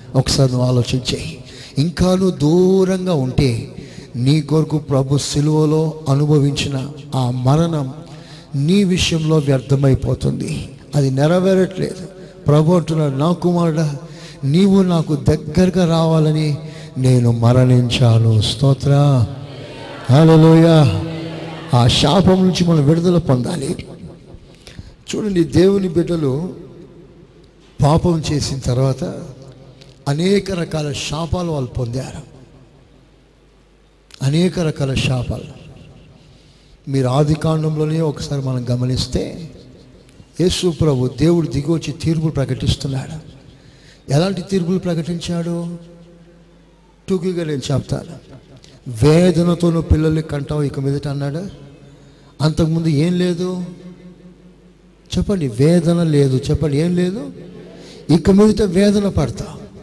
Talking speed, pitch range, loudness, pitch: 85 wpm, 135-170 Hz, -16 LUFS, 155 Hz